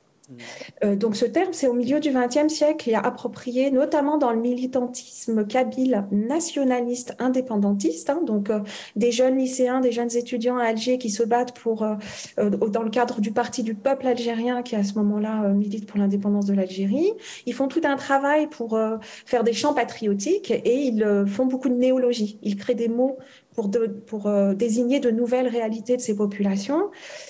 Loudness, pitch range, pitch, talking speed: -23 LUFS, 215-260 Hz, 245 Hz, 195 wpm